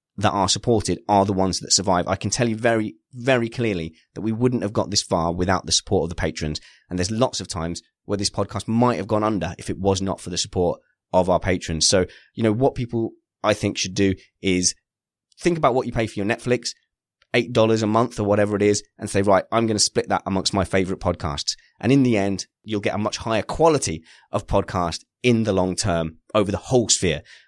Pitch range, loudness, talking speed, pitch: 90-115 Hz, -22 LUFS, 235 wpm, 100 Hz